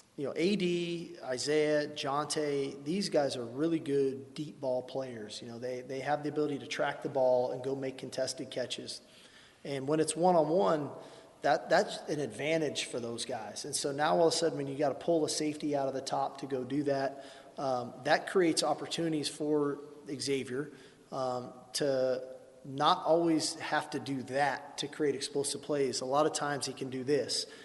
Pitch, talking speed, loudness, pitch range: 145 Hz, 195 wpm, -33 LUFS, 135-155 Hz